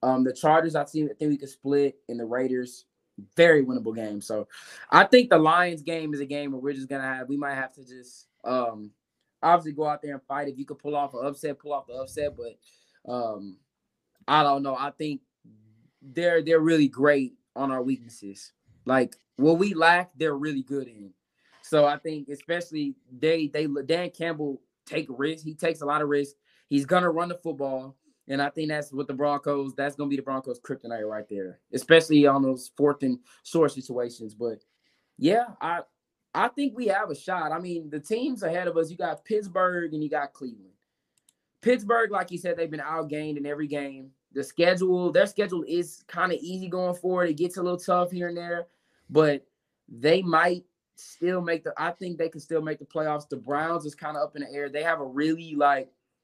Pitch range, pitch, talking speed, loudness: 135-165 Hz, 145 Hz, 210 wpm, -26 LUFS